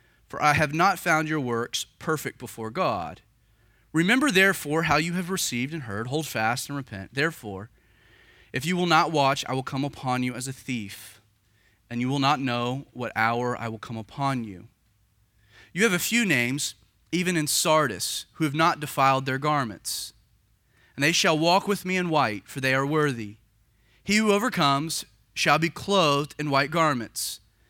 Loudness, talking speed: -25 LUFS, 180 wpm